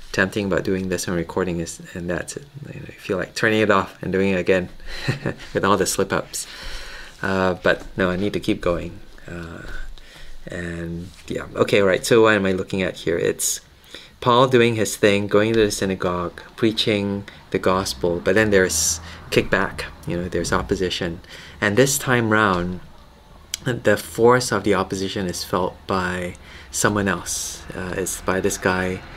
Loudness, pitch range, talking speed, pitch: -21 LUFS, 85-105 Hz, 175 wpm, 95 Hz